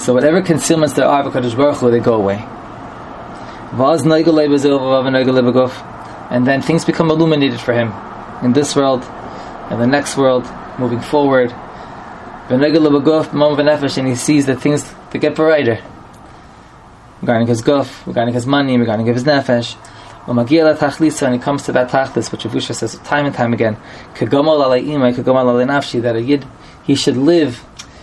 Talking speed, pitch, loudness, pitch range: 125 wpm, 130 Hz, -14 LUFS, 120-145 Hz